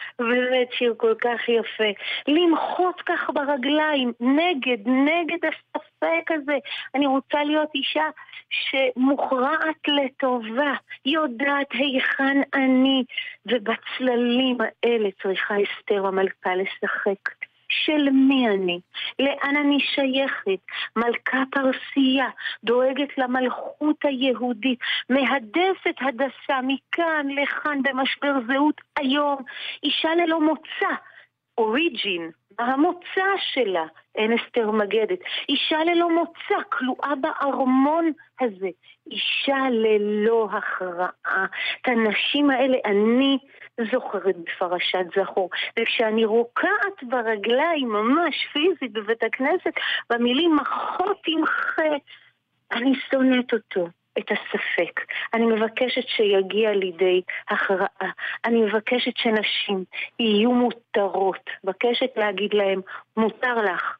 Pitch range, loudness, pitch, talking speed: 225-300 Hz, -23 LUFS, 260 Hz, 95 wpm